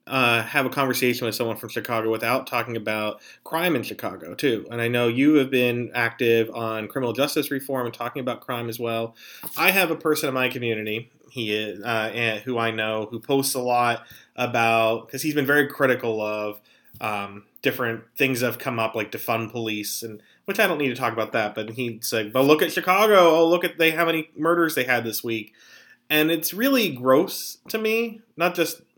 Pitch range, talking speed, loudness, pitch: 115-145 Hz, 210 wpm, -23 LUFS, 120 Hz